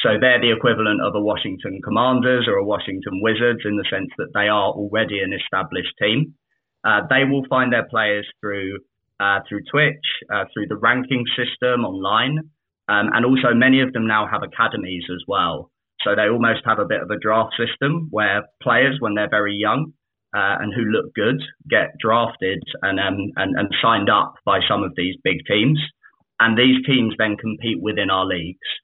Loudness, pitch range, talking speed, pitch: -19 LUFS, 105-130 Hz, 190 wpm, 115 Hz